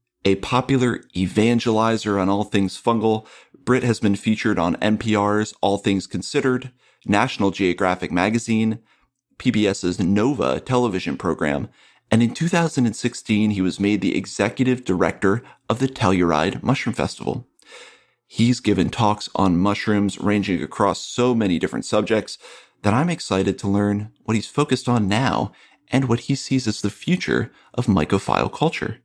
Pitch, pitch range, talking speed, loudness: 105 Hz, 100-120 Hz, 140 wpm, -21 LUFS